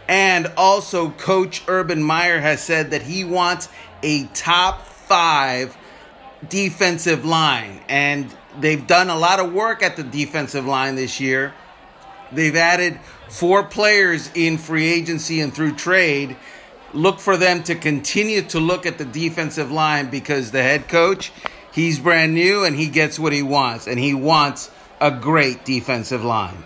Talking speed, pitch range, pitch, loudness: 155 wpm, 145-180 Hz, 160 Hz, -18 LUFS